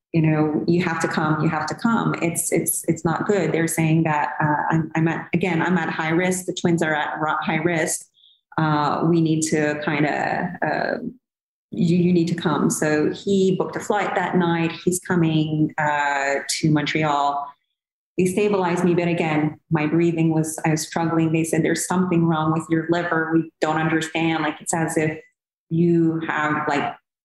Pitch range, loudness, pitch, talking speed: 155-175 Hz, -21 LUFS, 165 Hz, 190 wpm